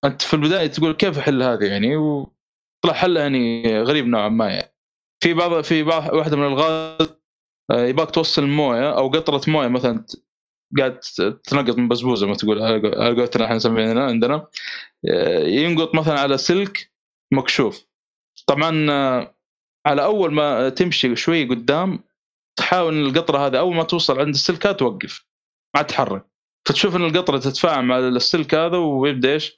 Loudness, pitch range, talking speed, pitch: -19 LUFS, 125-165 Hz, 150 wpm, 150 Hz